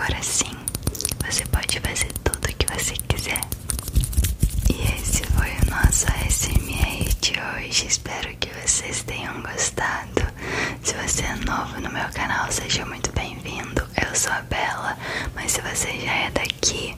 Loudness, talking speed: -23 LUFS, 155 wpm